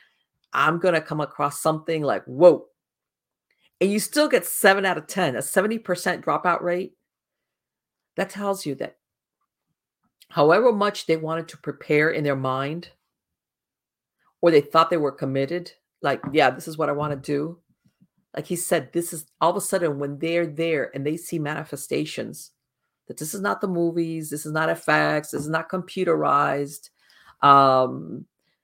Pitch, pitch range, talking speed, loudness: 160 Hz, 145-175 Hz, 170 wpm, -23 LUFS